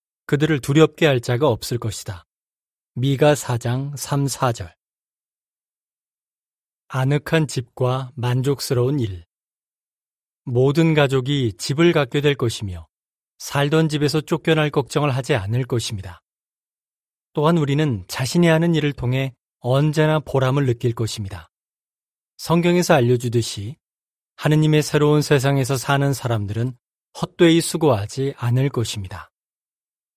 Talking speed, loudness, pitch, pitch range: 250 characters per minute, -20 LUFS, 135 Hz, 120-150 Hz